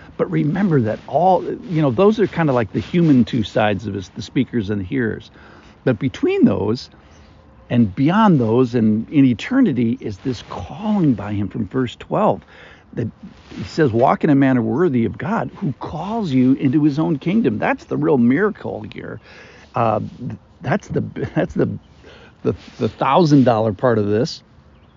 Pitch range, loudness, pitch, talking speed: 110-165 Hz, -18 LUFS, 130 Hz, 175 wpm